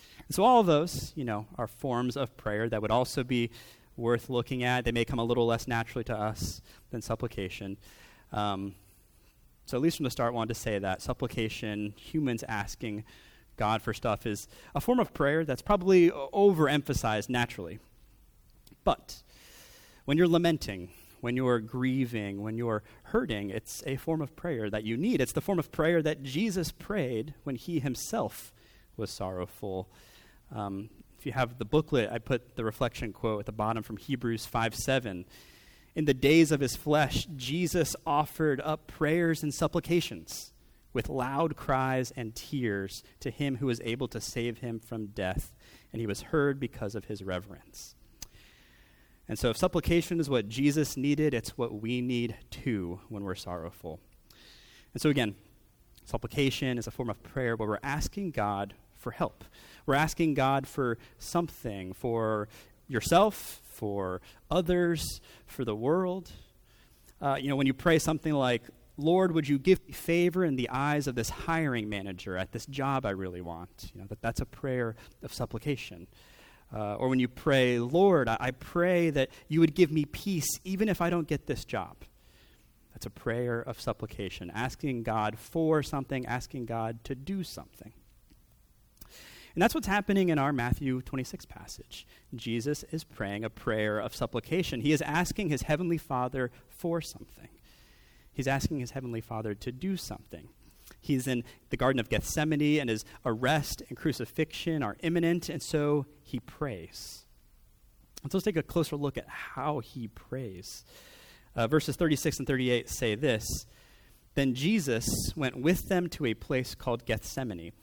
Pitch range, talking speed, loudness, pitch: 110-150 Hz, 170 wpm, -31 LUFS, 125 Hz